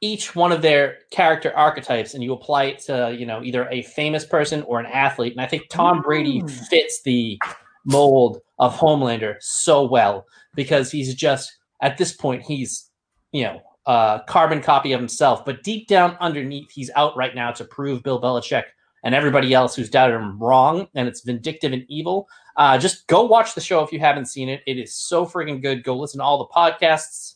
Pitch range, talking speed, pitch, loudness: 125-160 Hz, 200 wpm, 140 Hz, -19 LUFS